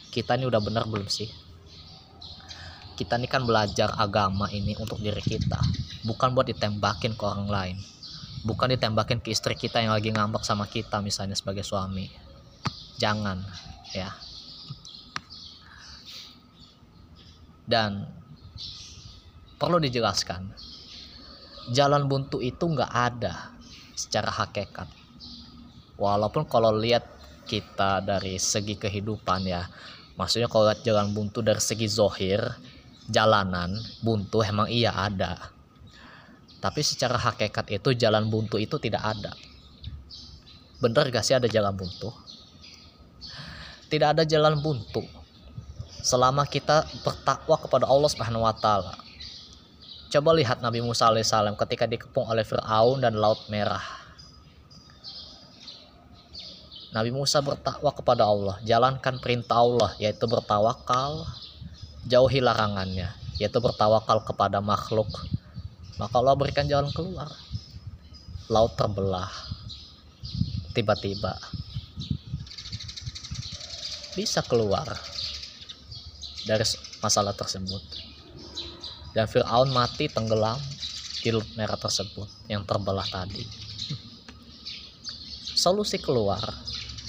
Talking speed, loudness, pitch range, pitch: 100 wpm, -26 LUFS, 95-120 Hz, 110 Hz